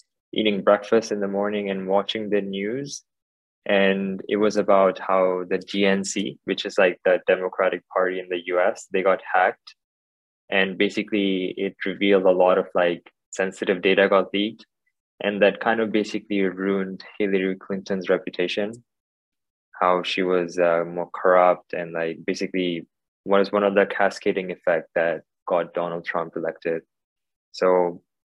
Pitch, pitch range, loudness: 95 Hz, 90-100 Hz, -23 LUFS